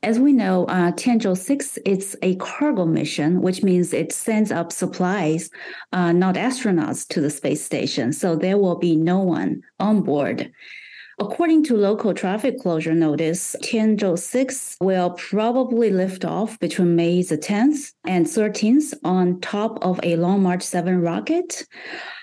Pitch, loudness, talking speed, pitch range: 185 Hz, -21 LUFS, 155 wpm, 175-225 Hz